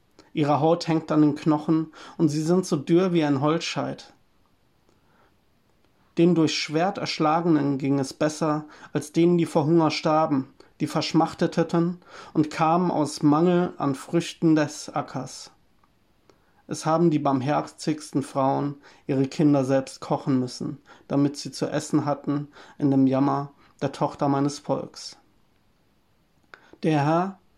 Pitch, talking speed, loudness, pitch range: 155 Hz, 135 wpm, -24 LUFS, 145-165 Hz